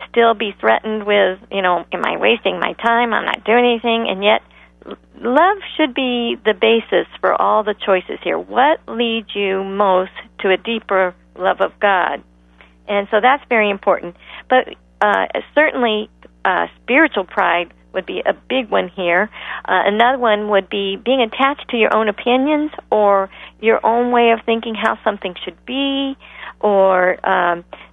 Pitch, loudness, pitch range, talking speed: 215 Hz, -17 LUFS, 195-240 Hz, 165 wpm